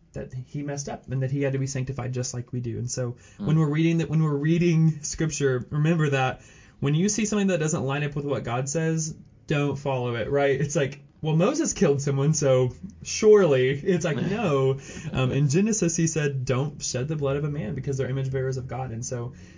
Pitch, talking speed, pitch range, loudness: 140 Hz, 225 wpm, 130-160 Hz, -25 LUFS